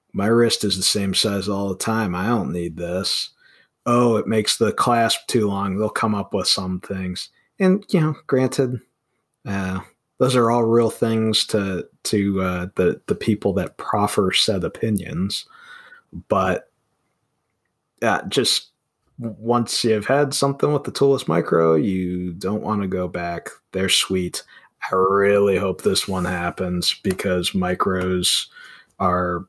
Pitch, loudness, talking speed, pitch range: 100 Hz, -20 LUFS, 150 wpm, 90-120 Hz